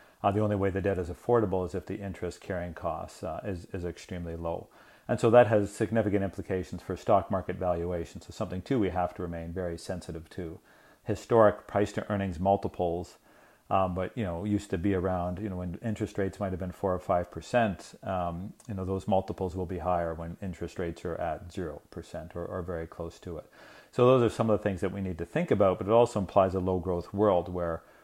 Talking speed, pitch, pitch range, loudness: 230 wpm, 95 Hz, 90-105 Hz, -30 LUFS